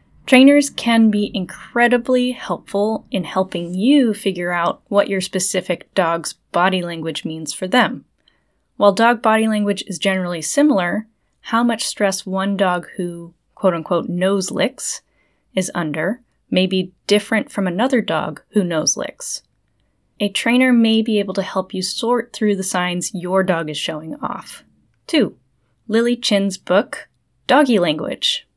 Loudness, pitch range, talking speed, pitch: -18 LUFS, 180-225 Hz, 145 wpm, 195 Hz